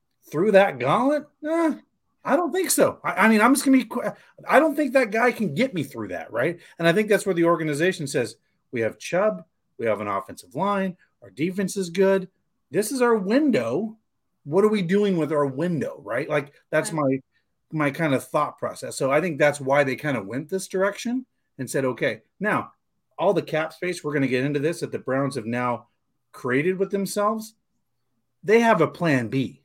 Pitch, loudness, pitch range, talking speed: 180 Hz, -23 LUFS, 145-215 Hz, 215 wpm